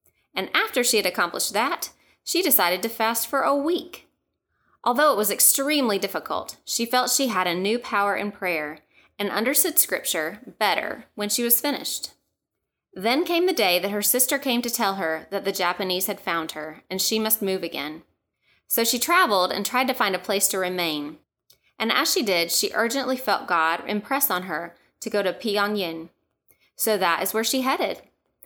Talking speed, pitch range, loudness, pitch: 190 wpm, 185-250 Hz, -23 LUFS, 205 Hz